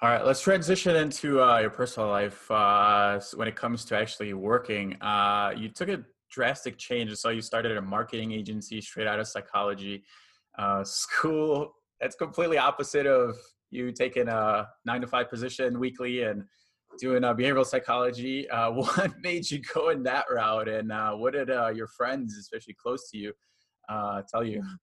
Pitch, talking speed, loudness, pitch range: 115 Hz, 180 wpm, -28 LUFS, 105-130 Hz